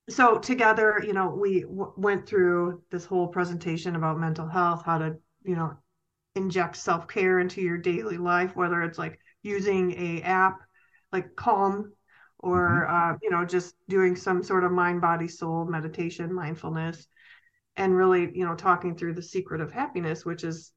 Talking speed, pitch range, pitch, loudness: 170 wpm, 170-190 Hz, 180 Hz, -26 LUFS